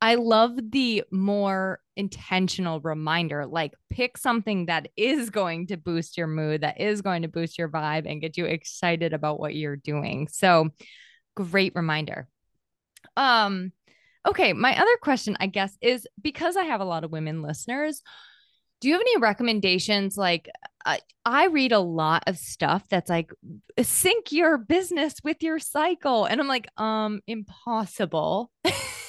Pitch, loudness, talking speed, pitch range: 195 Hz, -25 LUFS, 155 wpm, 165-250 Hz